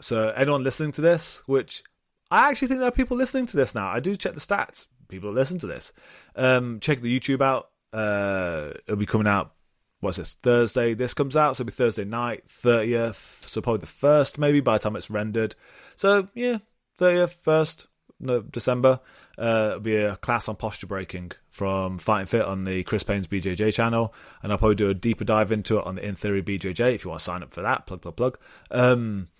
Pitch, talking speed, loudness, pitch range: 115 Hz, 215 wpm, -24 LUFS, 105-135 Hz